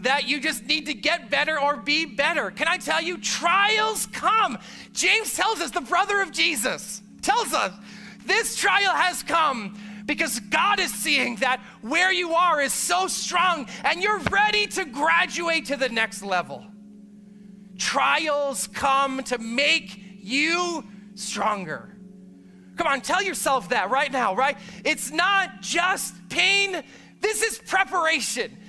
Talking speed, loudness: 145 wpm, -22 LUFS